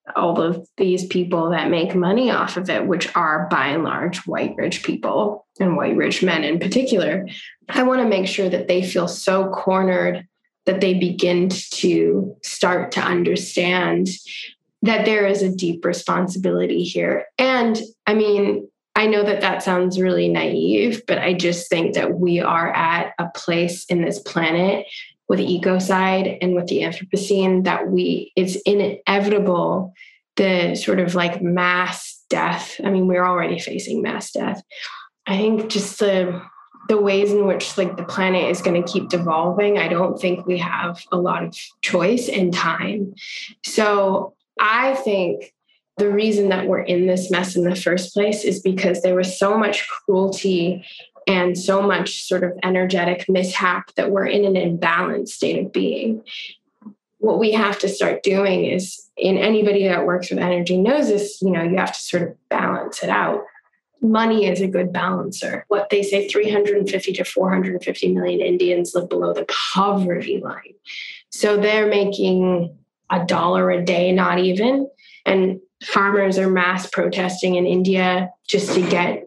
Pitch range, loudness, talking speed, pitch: 180-200 Hz, -19 LUFS, 165 wpm, 185 Hz